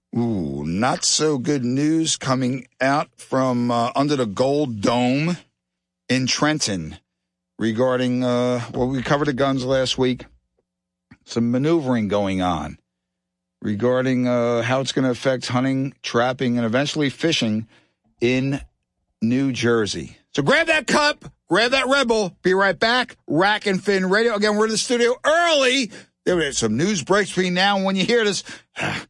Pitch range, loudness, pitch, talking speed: 120-180 Hz, -20 LUFS, 130 Hz, 155 wpm